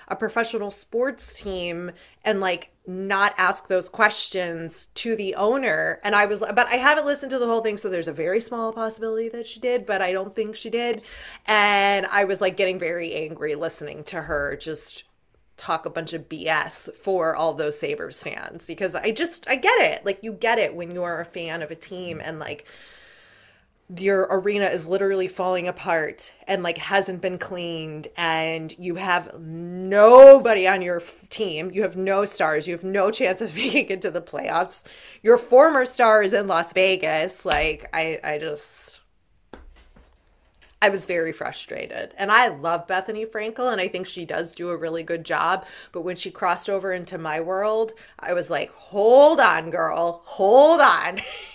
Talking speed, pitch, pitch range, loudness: 185 wpm, 190 Hz, 170-220 Hz, -21 LUFS